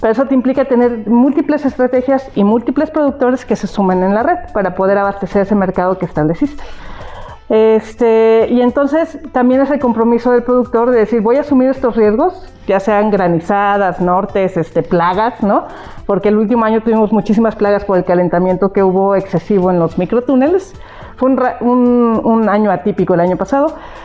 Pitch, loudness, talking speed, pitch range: 220 Hz, -13 LUFS, 175 wpm, 195-255 Hz